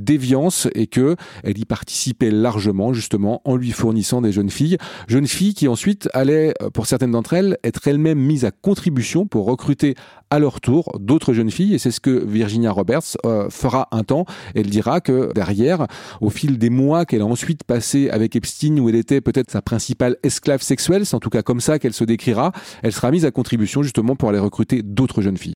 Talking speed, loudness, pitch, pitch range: 210 wpm, -18 LUFS, 125 Hz, 115-145 Hz